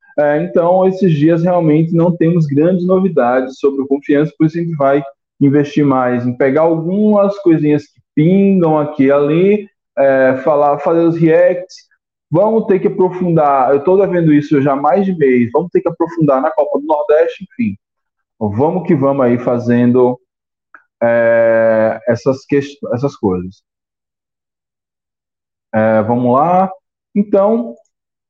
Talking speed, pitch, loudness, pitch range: 150 wpm, 150 Hz, -13 LUFS, 135-180 Hz